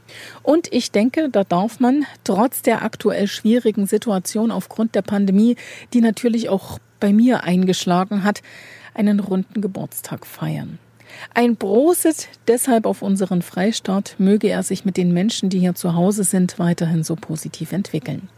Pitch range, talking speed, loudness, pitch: 185-230 Hz, 150 wpm, -19 LUFS, 205 Hz